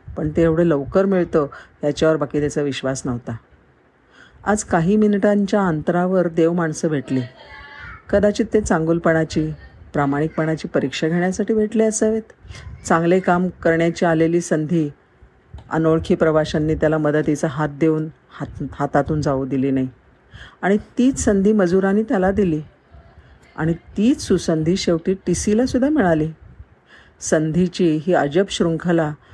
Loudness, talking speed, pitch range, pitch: -19 LUFS, 120 wpm, 150-190 Hz, 165 Hz